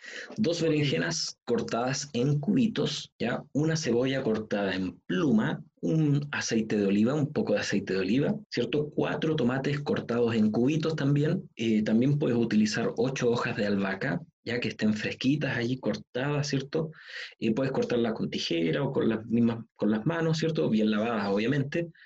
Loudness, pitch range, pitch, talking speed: -28 LUFS, 110-155 Hz, 125 Hz, 165 wpm